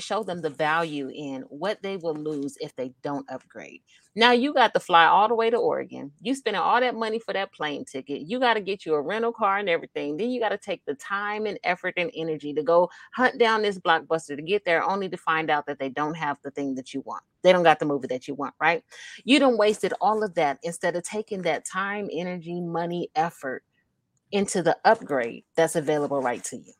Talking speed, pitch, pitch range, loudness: 235 wpm, 175 Hz, 150-210 Hz, -25 LUFS